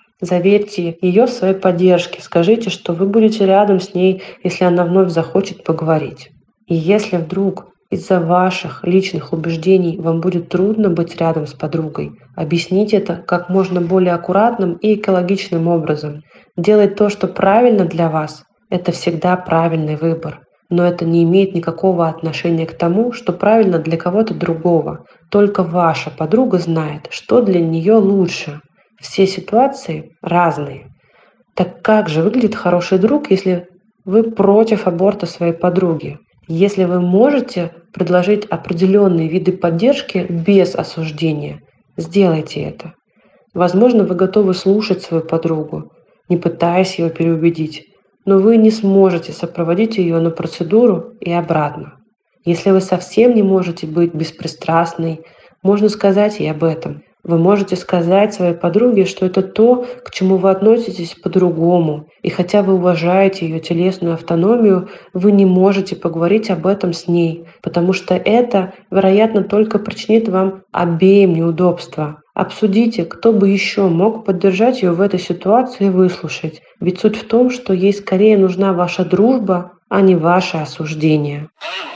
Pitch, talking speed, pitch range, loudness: 185 Hz, 140 wpm, 170-200 Hz, -15 LUFS